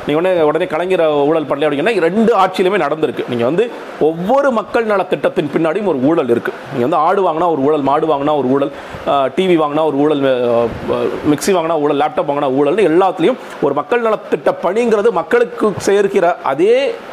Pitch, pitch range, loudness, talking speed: 180 Hz, 150-240 Hz, -14 LUFS, 170 wpm